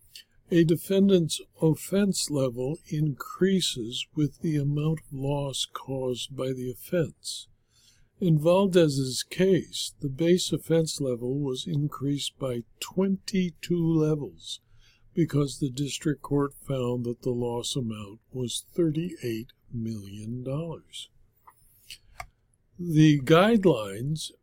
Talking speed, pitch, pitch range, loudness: 100 wpm, 145 Hz, 125-165 Hz, -27 LUFS